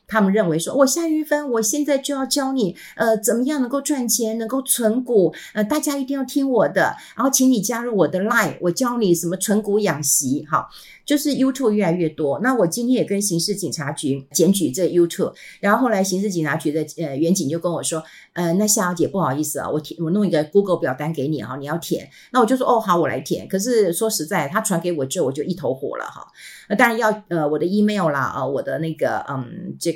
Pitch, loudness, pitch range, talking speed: 200 Hz, -20 LUFS, 165-240 Hz, 380 characters per minute